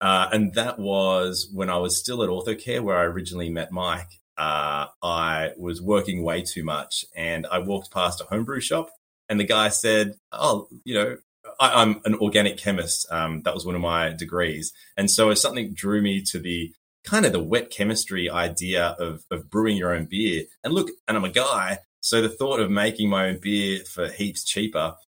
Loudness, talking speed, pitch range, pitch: -24 LUFS, 200 wpm, 85-105 Hz, 90 Hz